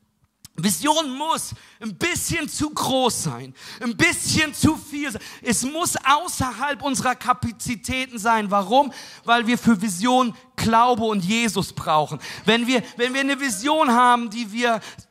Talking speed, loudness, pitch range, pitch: 140 wpm, -21 LUFS, 225-270 Hz, 245 Hz